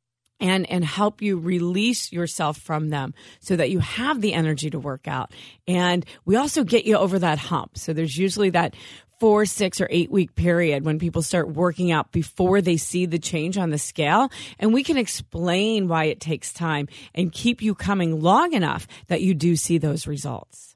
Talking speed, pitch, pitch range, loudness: 195 wpm, 175 Hz, 155-195 Hz, -22 LUFS